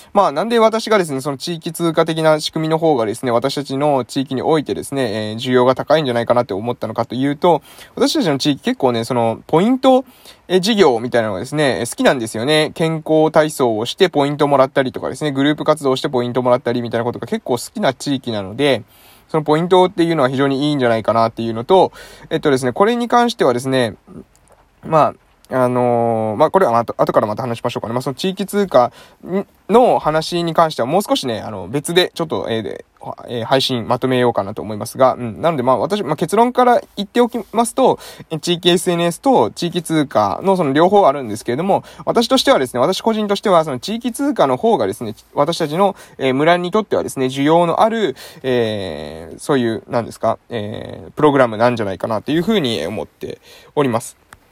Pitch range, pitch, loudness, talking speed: 120-180 Hz, 145 Hz, -17 LUFS, 440 characters per minute